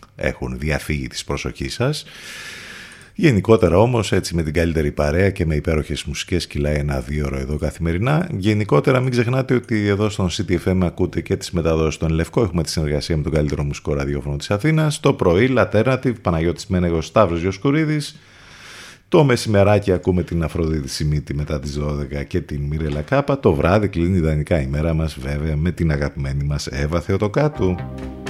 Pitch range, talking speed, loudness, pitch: 75-105 Hz, 165 wpm, -20 LUFS, 85 Hz